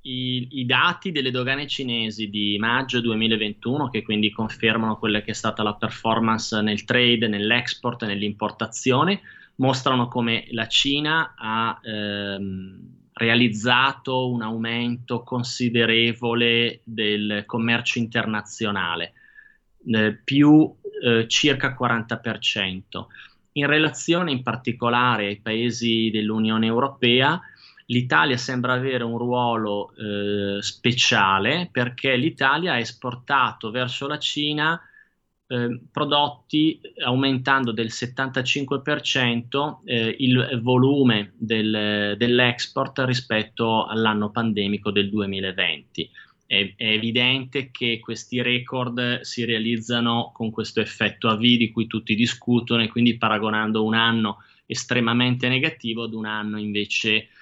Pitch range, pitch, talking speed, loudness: 110-125 Hz, 120 Hz, 110 wpm, -22 LUFS